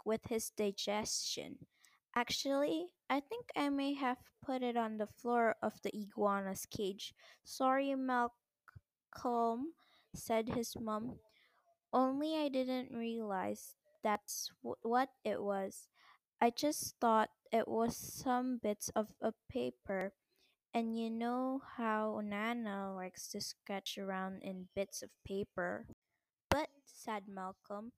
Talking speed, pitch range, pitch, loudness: 125 wpm, 205-255 Hz, 230 Hz, -39 LUFS